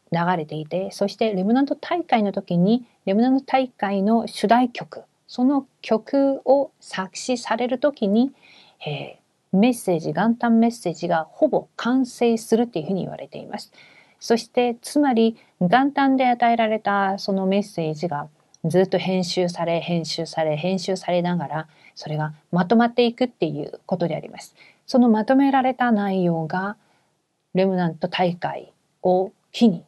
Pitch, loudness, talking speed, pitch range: 200 Hz, -22 LUFS, 315 characters per minute, 180-245 Hz